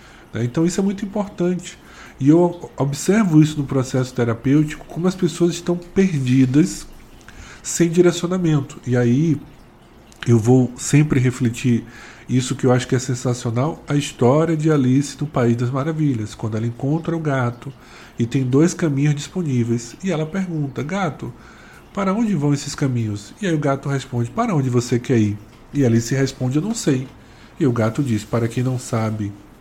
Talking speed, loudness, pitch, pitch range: 170 wpm, -20 LUFS, 135 Hz, 120-160 Hz